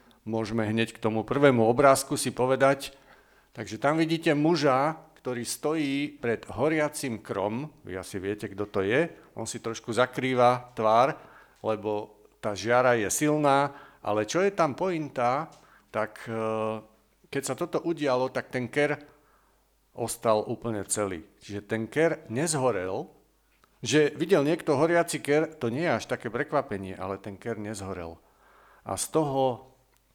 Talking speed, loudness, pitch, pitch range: 140 wpm, -27 LUFS, 125 Hz, 110-145 Hz